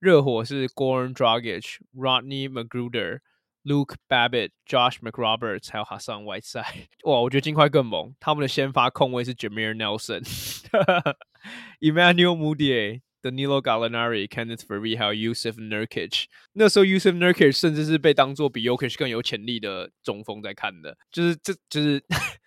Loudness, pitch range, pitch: -23 LUFS, 115-150 Hz, 130 Hz